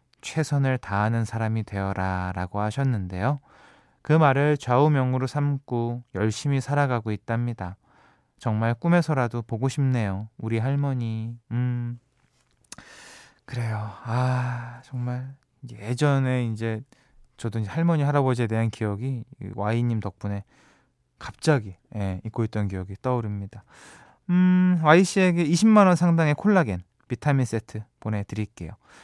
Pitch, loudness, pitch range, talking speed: 120 Hz, -25 LUFS, 110-140 Hz, 270 characters per minute